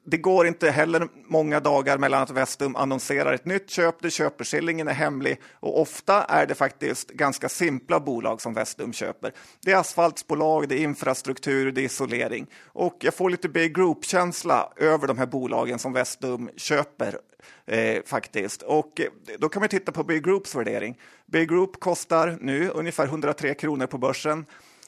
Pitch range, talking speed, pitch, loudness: 135-170 Hz, 165 wpm, 155 Hz, -24 LUFS